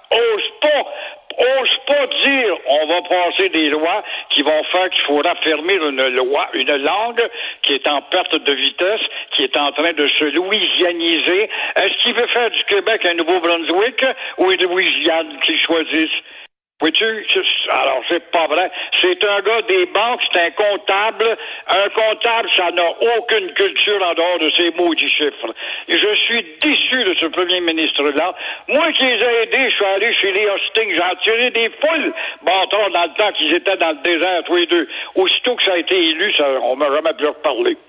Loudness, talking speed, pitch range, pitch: -15 LUFS, 190 wpm, 165-255 Hz, 195 Hz